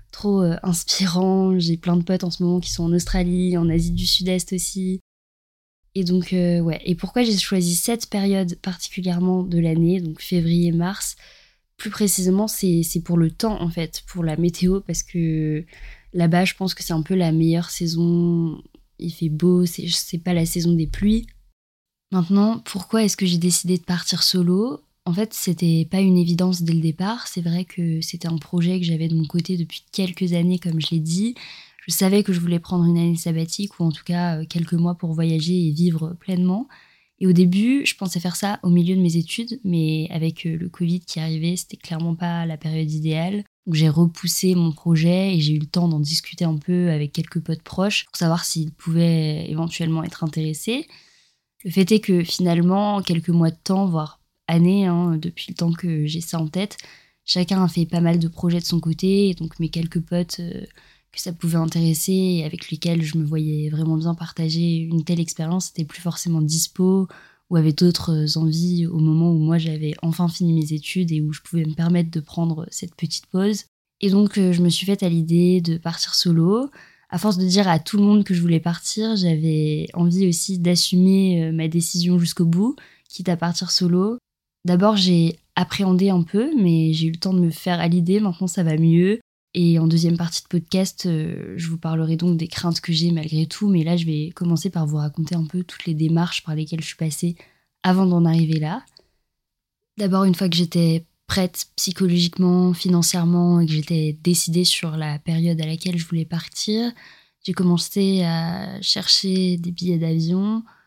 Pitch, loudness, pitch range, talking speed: 175 Hz, -21 LUFS, 165-185 Hz, 200 wpm